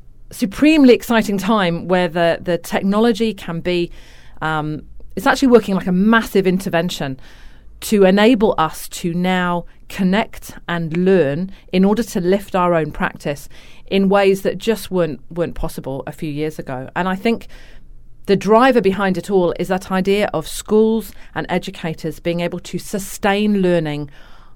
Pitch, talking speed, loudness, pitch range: 185 Hz, 155 wpm, -17 LUFS, 170-205 Hz